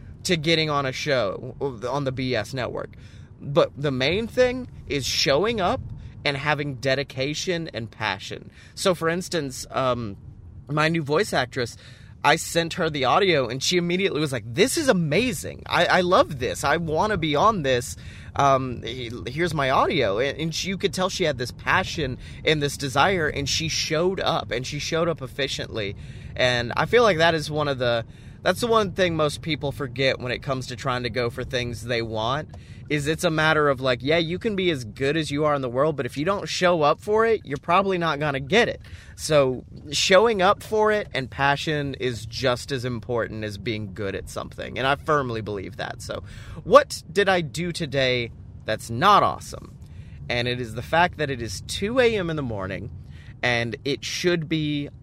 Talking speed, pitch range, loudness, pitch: 200 wpm, 120-165 Hz, -23 LUFS, 140 Hz